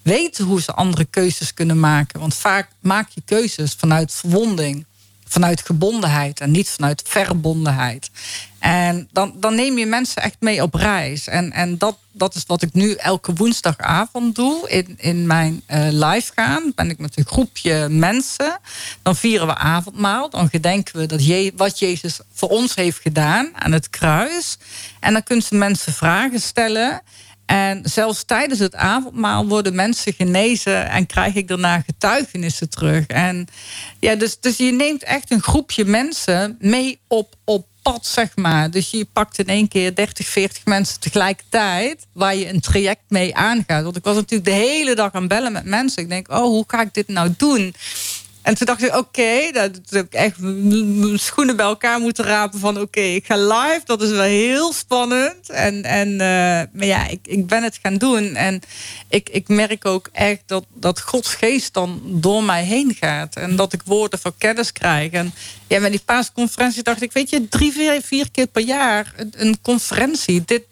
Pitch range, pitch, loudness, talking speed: 175-225 Hz, 200 Hz, -18 LUFS, 190 wpm